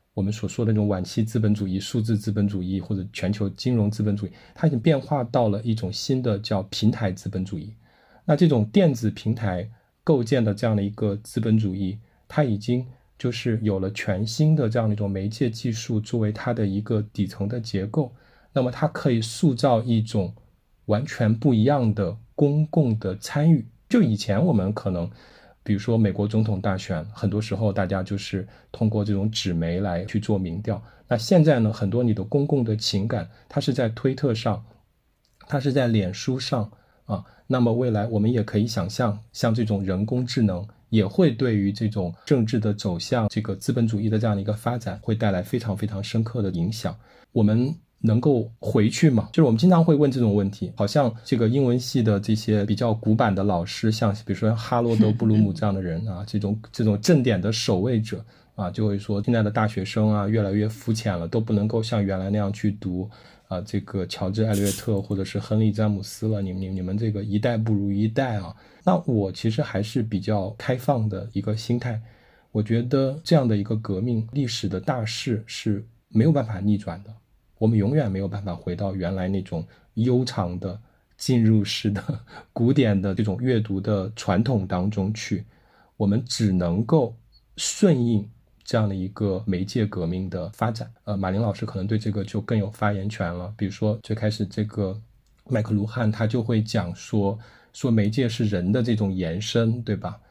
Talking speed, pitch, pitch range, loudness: 295 characters per minute, 110 Hz, 100-120 Hz, -24 LUFS